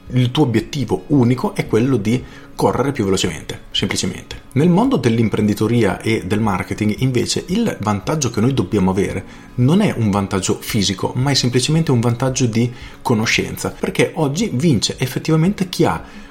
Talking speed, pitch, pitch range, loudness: 155 wpm, 125 Hz, 110-145 Hz, -18 LUFS